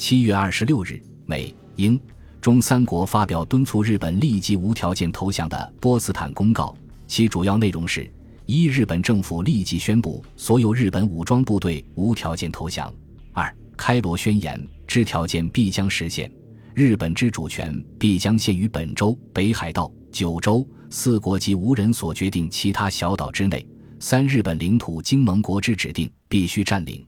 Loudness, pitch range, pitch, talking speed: -22 LUFS, 85-115 Hz, 100 Hz, 255 characters per minute